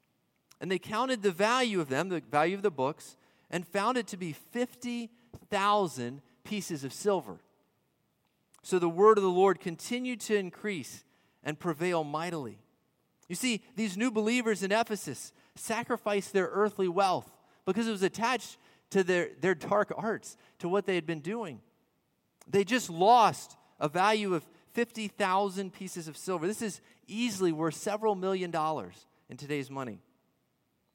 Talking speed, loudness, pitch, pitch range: 155 wpm, -31 LUFS, 190 Hz, 170-215 Hz